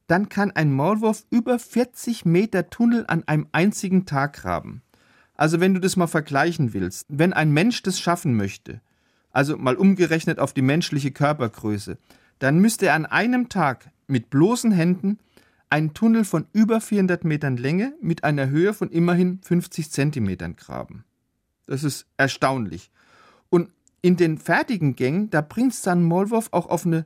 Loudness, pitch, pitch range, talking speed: -22 LUFS, 170 Hz, 140-195 Hz, 160 wpm